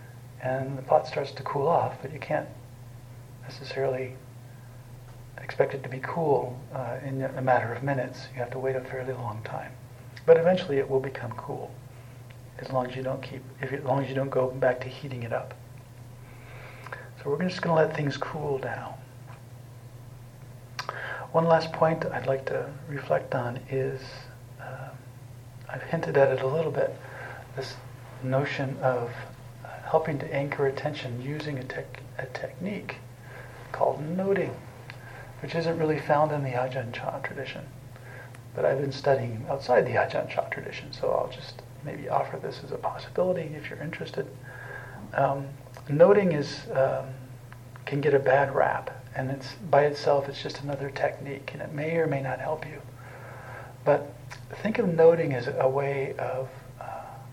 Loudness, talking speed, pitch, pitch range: -28 LUFS, 165 wpm, 130 Hz, 125-140 Hz